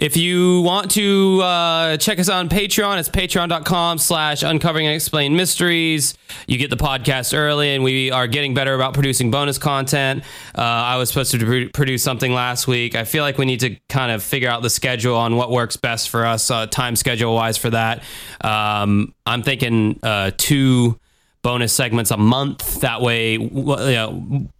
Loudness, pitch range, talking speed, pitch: -17 LUFS, 120-150 Hz, 190 wpm, 135 Hz